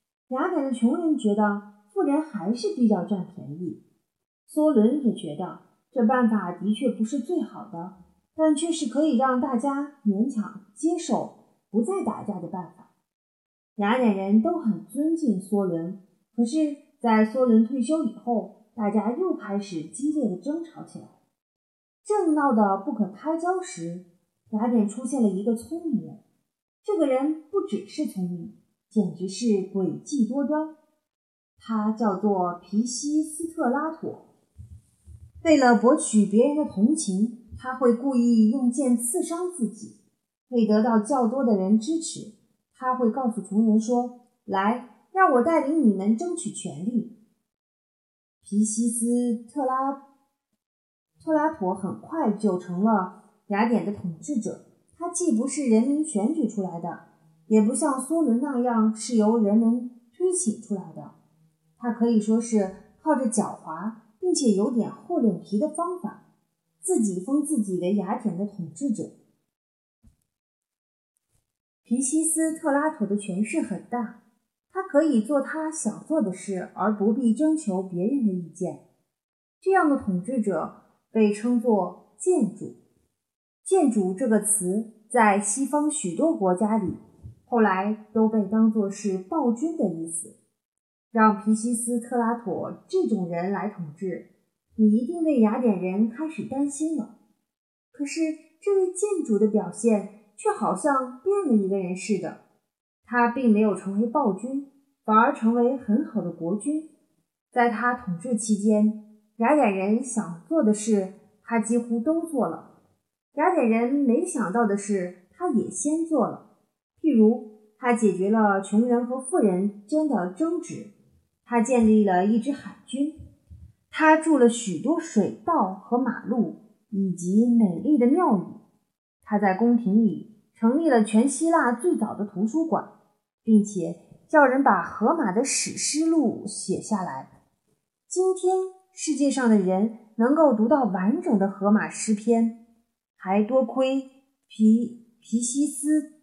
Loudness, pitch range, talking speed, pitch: -24 LUFS, 205-280 Hz, 205 characters per minute, 230 Hz